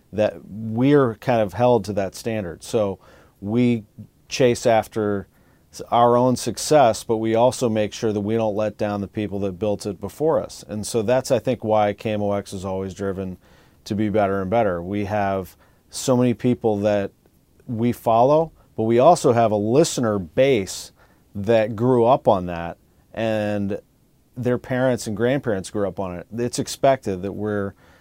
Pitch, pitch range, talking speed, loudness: 105 Hz, 100-120 Hz, 170 wpm, -21 LUFS